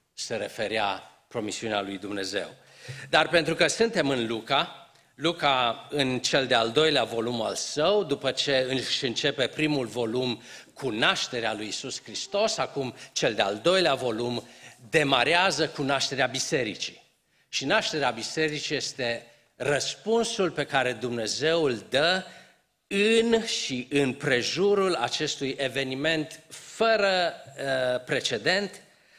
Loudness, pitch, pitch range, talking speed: -26 LUFS, 140 Hz, 125-170 Hz, 120 wpm